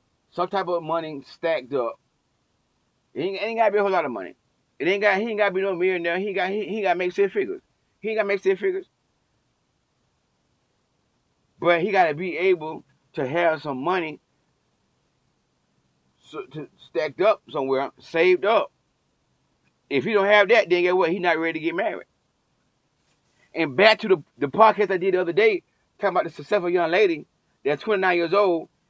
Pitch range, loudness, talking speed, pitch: 170-220 Hz, -22 LUFS, 190 wpm, 190 Hz